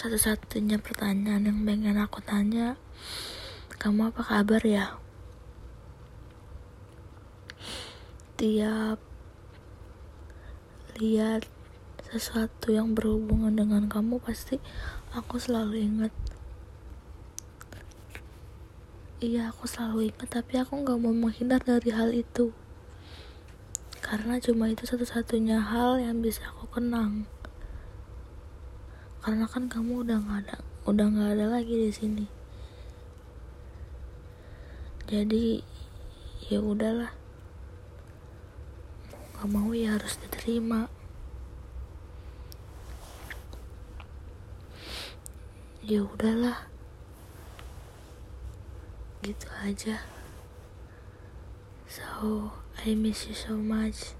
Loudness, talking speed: -30 LUFS, 80 wpm